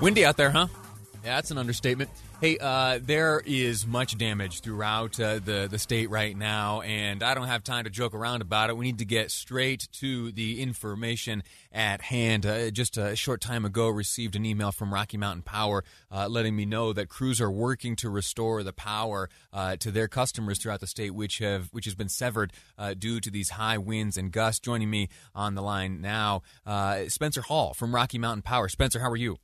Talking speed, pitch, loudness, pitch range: 210 wpm, 110 Hz, -28 LUFS, 105-120 Hz